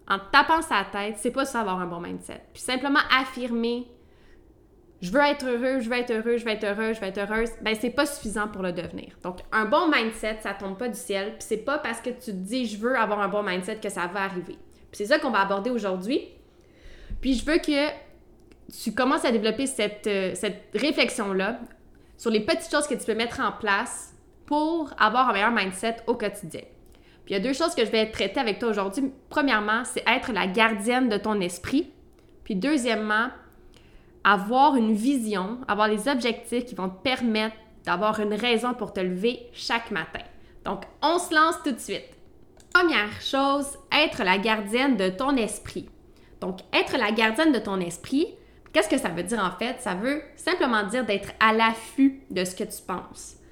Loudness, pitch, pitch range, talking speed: -25 LUFS, 230 Hz, 205-275 Hz, 205 wpm